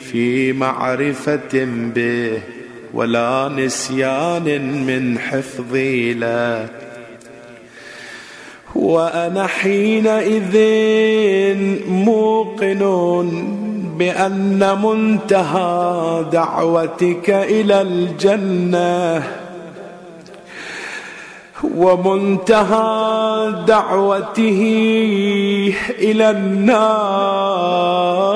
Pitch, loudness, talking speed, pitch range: 190 Hz, -16 LUFS, 40 wpm, 160-210 Hz